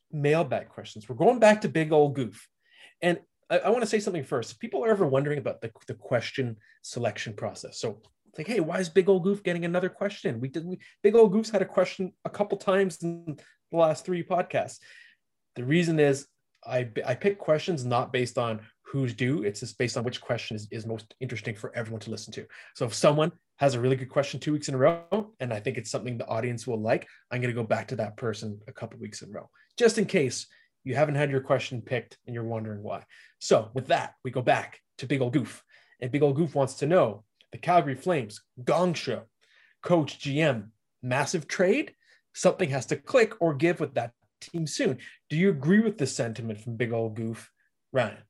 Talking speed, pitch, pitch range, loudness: 225 wpm, 140 Hz, 120-175 Hz, -27 LUFS